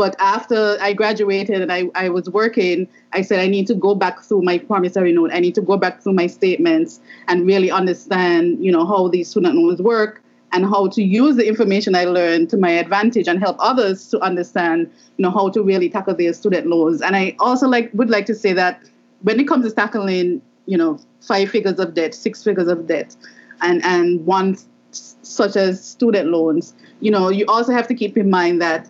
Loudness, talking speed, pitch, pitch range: -17 LUFS, 220 wpm, 190 Hz, 175-215 Hz